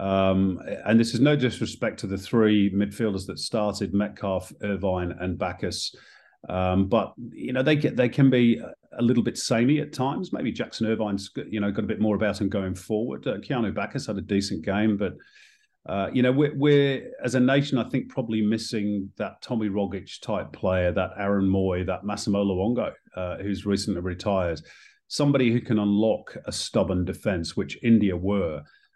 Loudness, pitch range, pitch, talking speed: -25 LUFS, 95-120 Hz, 105 Hz, 185 wpm